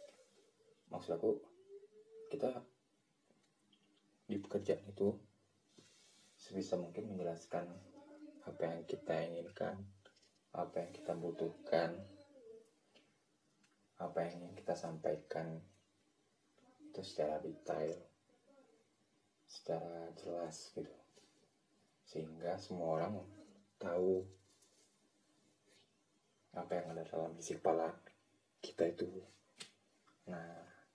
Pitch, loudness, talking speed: 100 Hz, -43 LUFS, 80 wpm